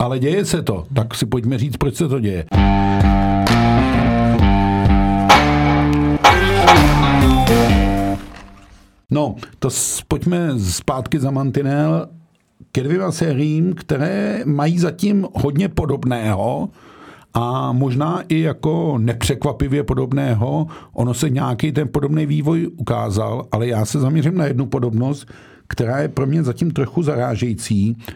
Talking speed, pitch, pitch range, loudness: 115 wpm, 130 Hz, 110-150 Hz, -17 LUFS